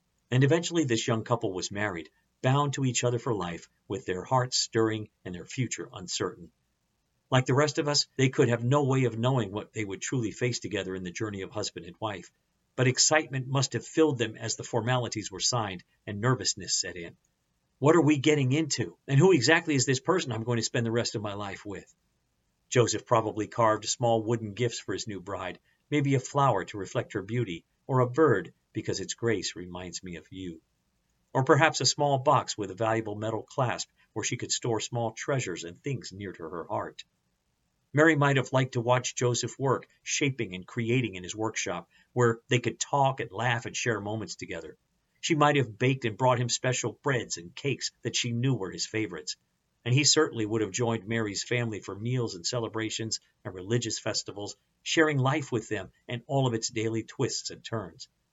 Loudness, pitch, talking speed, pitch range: -28 LUFS, 120 Hz, 205 wpm, 110-135 Hz